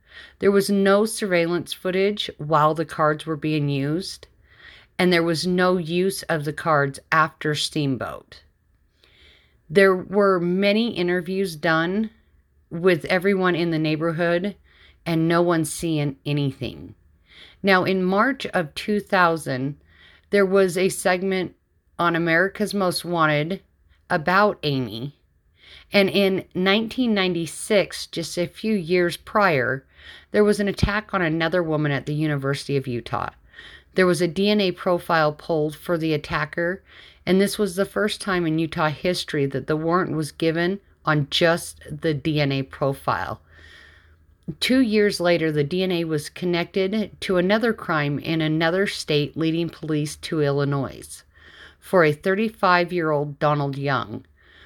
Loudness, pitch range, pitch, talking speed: -22 LUFS, 150-190 Hz, 170 Hz, 135 wpm